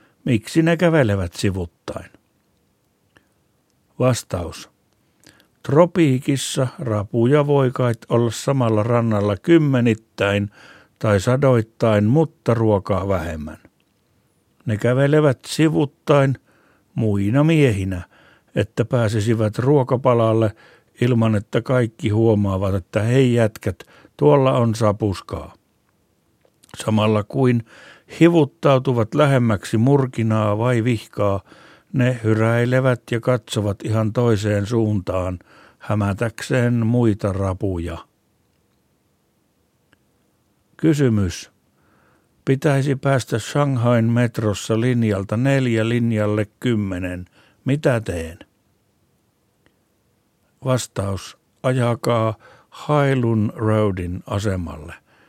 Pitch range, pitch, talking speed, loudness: 105-130 Hz, 115 Hz, 75 wpm, -19 LUFS